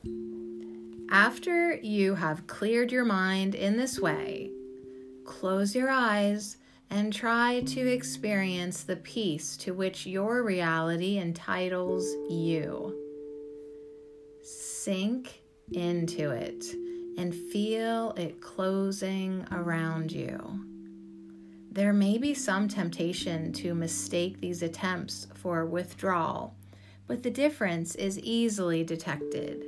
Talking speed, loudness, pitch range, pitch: 100 wpm, -30 LUFS, 145-200 Hz, 175 Hz